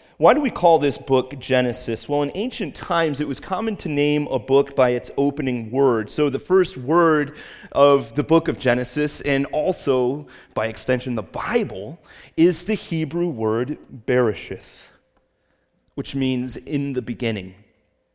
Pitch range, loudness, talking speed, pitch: 125-160 Hz, -21 LUFS, 155 wpm, 140 Hz